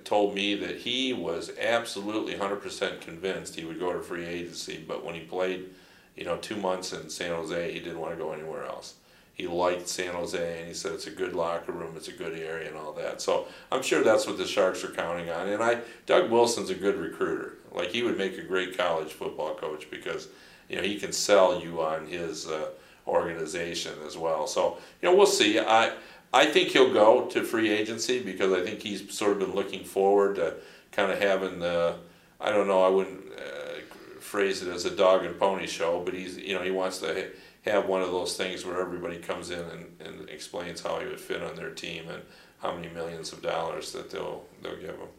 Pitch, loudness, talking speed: 105 Hz, -28 LUFS, 225 wpm